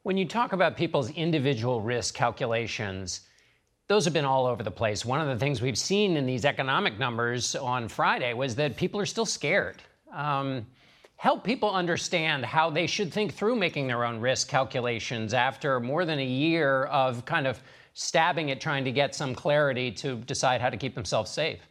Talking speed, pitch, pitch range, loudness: 190 wpm, 135 Hz, 125-165 Hz, -27 LUFS